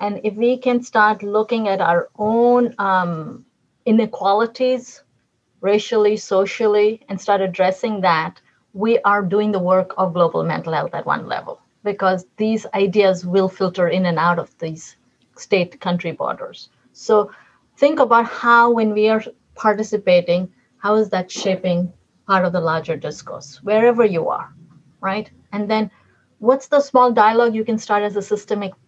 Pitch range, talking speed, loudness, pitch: 185-225 Hz, 155 wpm, -18 LUFS, 205 Hz